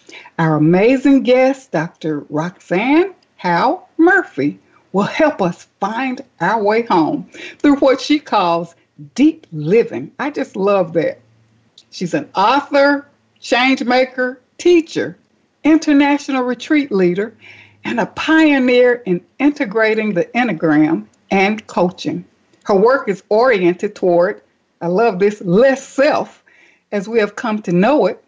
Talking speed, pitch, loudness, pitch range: 125 wpm, 230 Hz, -15 LUFS, 175-280 Hz